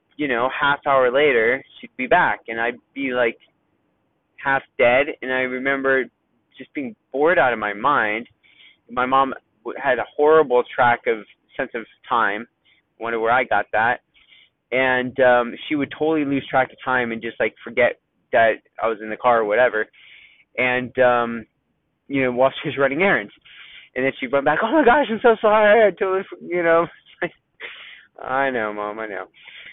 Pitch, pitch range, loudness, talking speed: 135 Hz, 125-155 Hz, -20 LUFS, 180 wpm